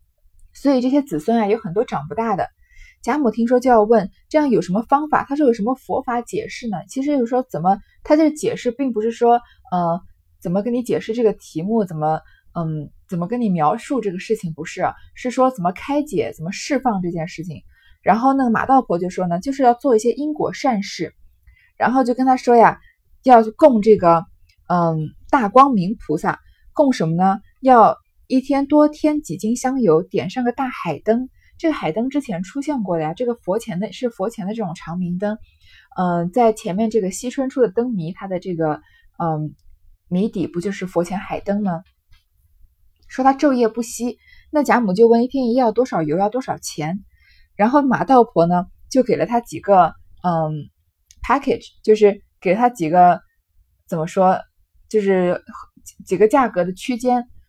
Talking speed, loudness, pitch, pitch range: 280 characters per minute, -19 LUFS, 215 Hz, 170-250 Hz